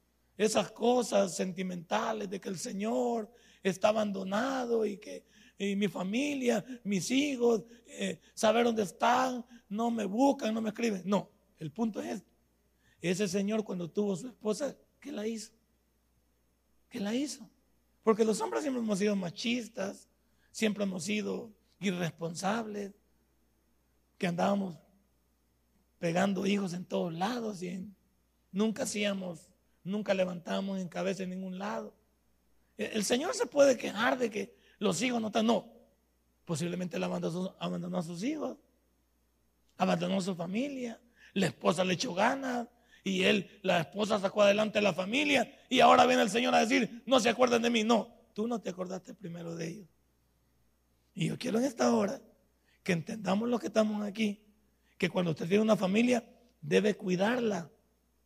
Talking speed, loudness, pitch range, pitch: 150 wpm, -31 LUFS, 180-230 Hz, 205 Hz